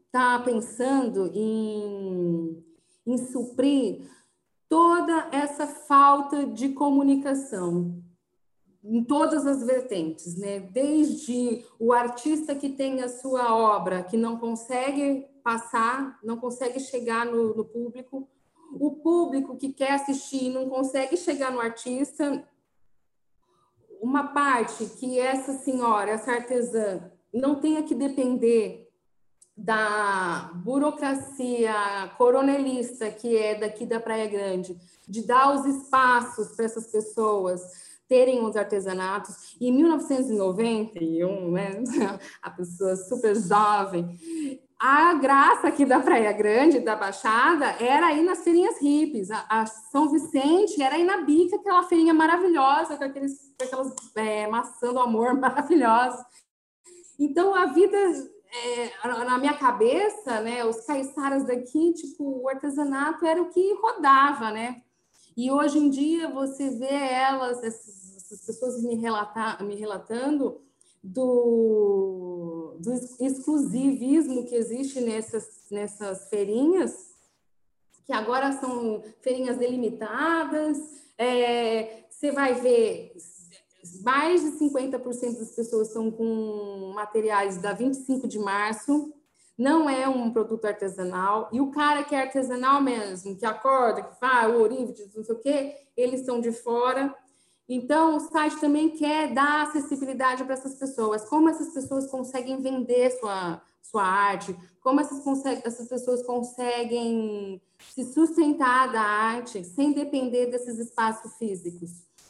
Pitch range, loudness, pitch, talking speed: 220-280 Hz, -25 LUFS, 250 Hz, 125 wpm